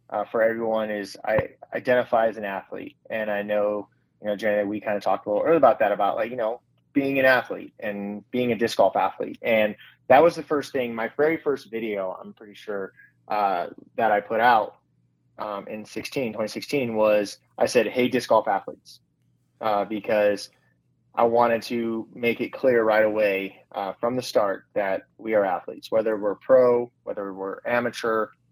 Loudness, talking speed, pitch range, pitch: -24 LUFS, 190 wpm, 105-120 Hz, 110 Hz